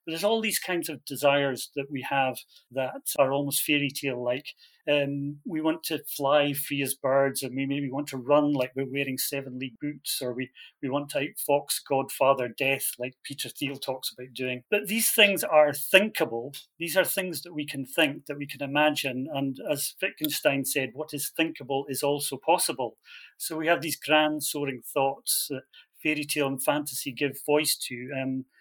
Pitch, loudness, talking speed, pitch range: 140 Hz, -27 LUFS, 190 wpm, 135-150 Hz